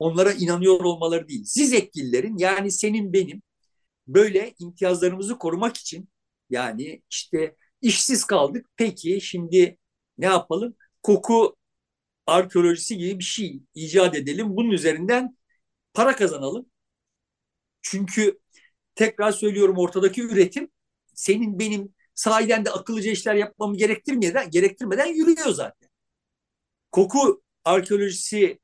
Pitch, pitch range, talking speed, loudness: 200 Hz, 180-230 Hz, 105 wpm, -22 LUFS